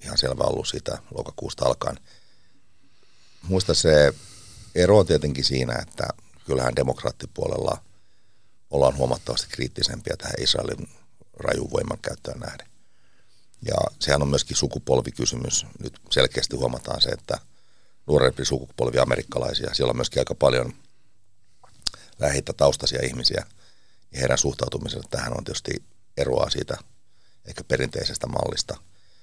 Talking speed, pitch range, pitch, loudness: 115 wpm, 65-100 Hz, 75 Hz, -24 LUFS